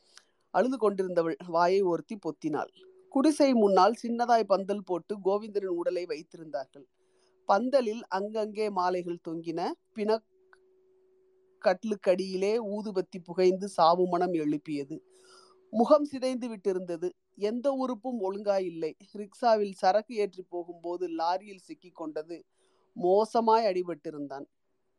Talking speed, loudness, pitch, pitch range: 90 wpm, -29 LUFS, 195 Hz, 175-235 Hz